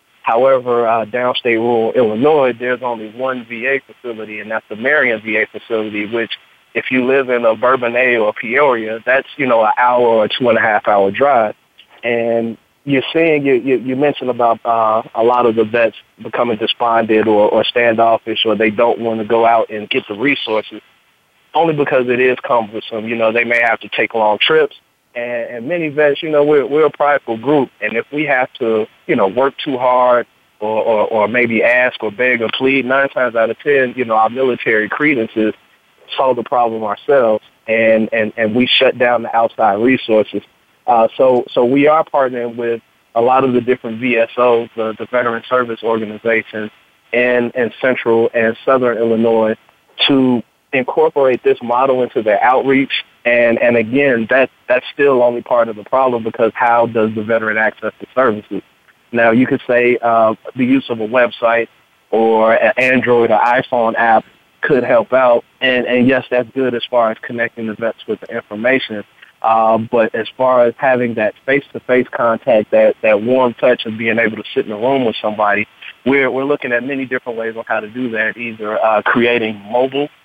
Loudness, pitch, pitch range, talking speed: -14 LUFS, 120 Hz, 110-130 Hz, 190 wpm